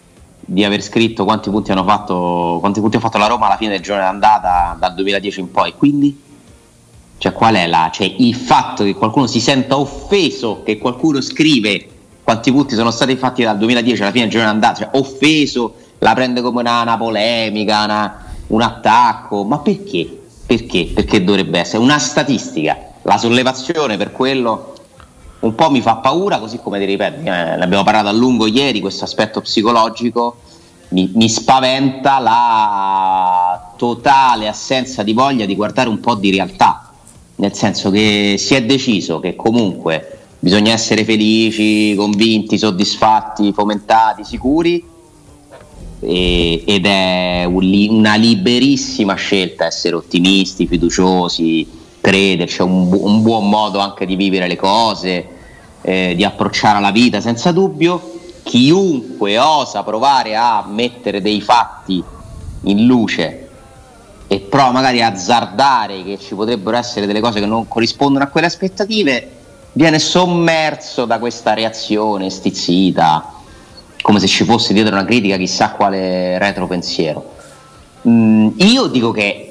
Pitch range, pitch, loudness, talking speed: 100-120 Hz, 110 Hz, -14 LUFS, 145 wpm